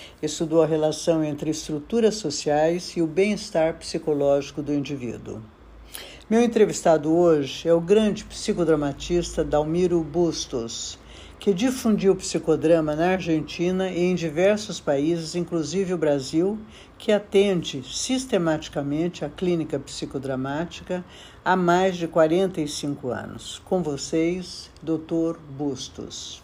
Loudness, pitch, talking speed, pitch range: -24 LUFS, 165 Hz, 110 wpm, 150-180 Hz